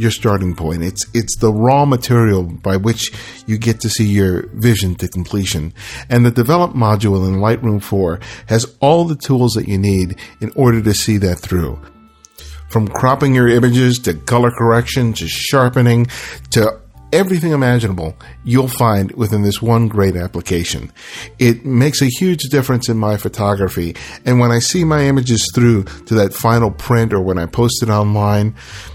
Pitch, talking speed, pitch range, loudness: 110 Hz, 170 wpm, 95-120 Hz, -15 LUFS